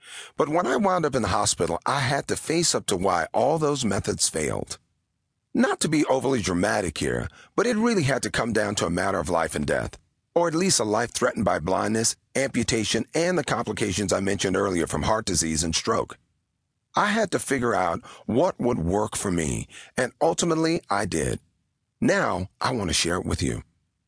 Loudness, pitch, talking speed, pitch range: -24 LUFS, 105 Hz, 200 wpm, 90-135 Hz